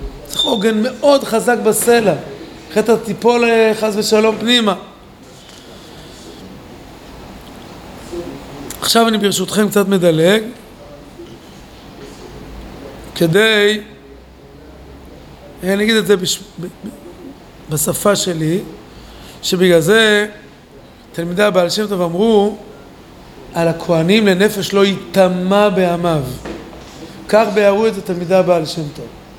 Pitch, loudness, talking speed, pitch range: 200 Hz, -14 LUFS, 85 wpm, 170-215 Hz